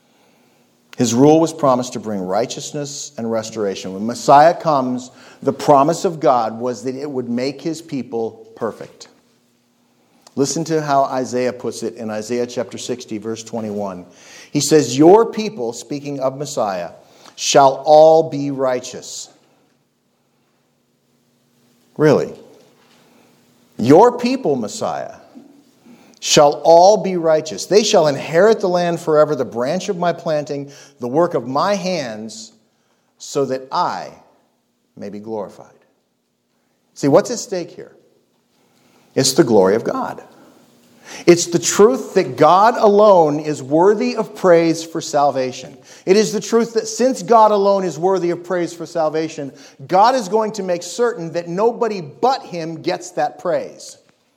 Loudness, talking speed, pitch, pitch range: -16 LUFS, 140 wpm, 150 Hz, 125-180 Hz